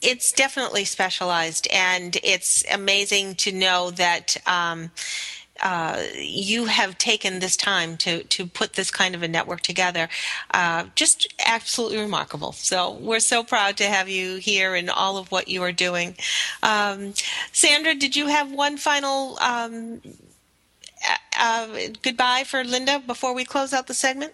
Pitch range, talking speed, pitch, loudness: 185-255 Hz, 155 wpm, 205 Hz, -21 LUFS